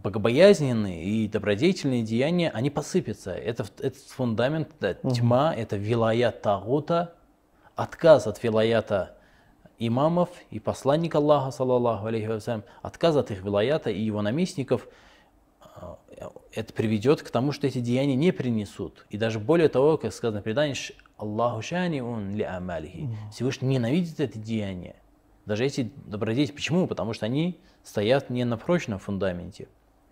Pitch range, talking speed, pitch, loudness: 110-150 Hz, 130 wpm, 120 Hz, -26 LUFS